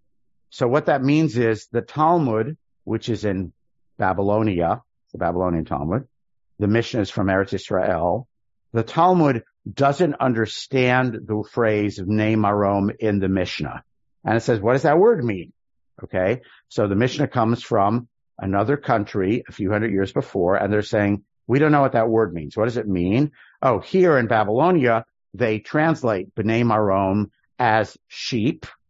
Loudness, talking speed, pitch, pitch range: -21 LUFS, 155 wpm, 110 Hz, 100-125 Hz